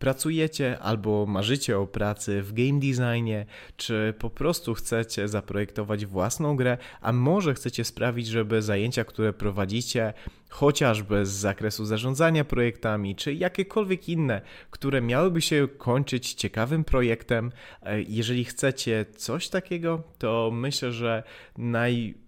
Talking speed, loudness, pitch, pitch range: 120 wpm, -27 LUFS, 120 Hz, 110-135 Hz